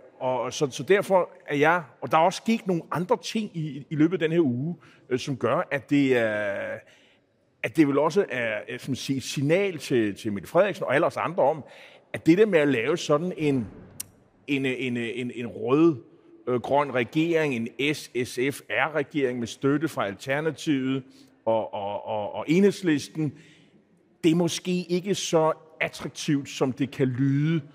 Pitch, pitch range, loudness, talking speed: 150 Hz, 130-165 Hz, -25 LUFS, 175 wpm